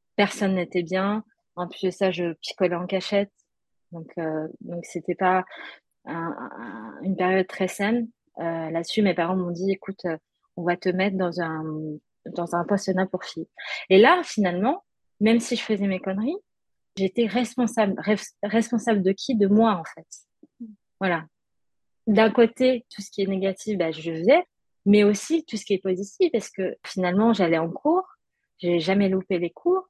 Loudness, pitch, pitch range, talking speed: -24 LUFS, 195 Hz, 180-220 Hz, 180 wpm